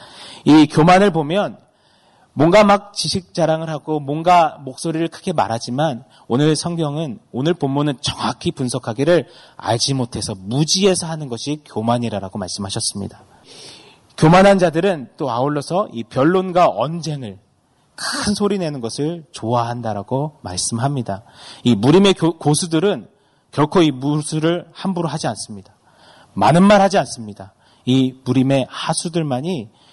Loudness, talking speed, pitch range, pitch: -18 LUFS, 300 characters per minute, 120-170 Hz, 150 Hz